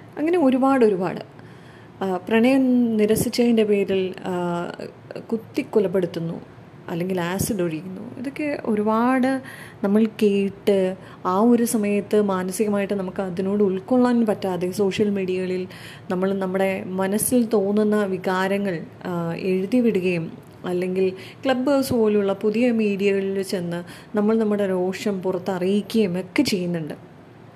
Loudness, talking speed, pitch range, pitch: -22 LUFS, 95 wpm, 185-220 Hz, 200 Hz